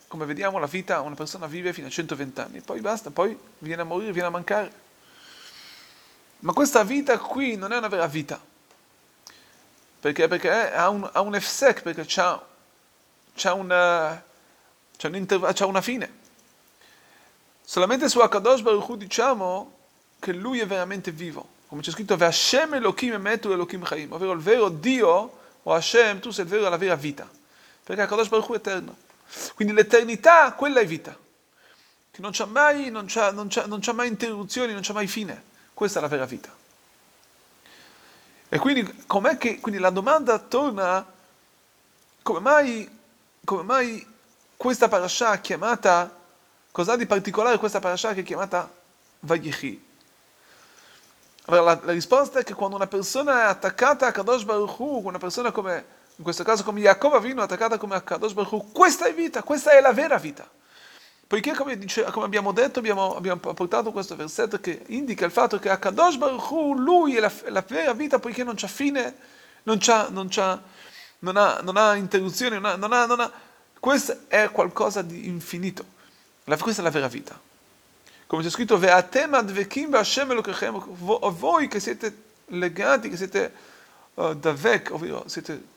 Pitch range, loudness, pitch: 185-245 Hz, -23 LUFS, 210 Hz